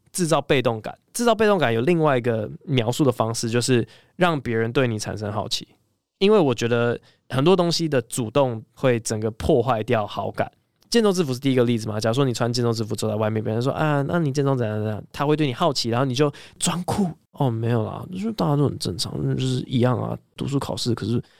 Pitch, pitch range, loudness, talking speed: 125 Hz, 115-150 Hz, -22 LUFS, 340 characters per minute